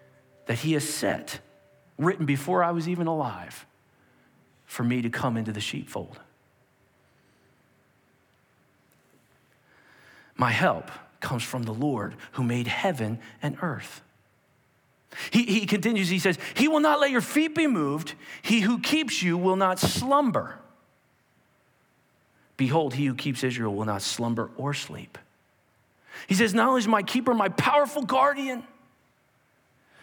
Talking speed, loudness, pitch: 135 wpm, -26 LUFS, 160 Hz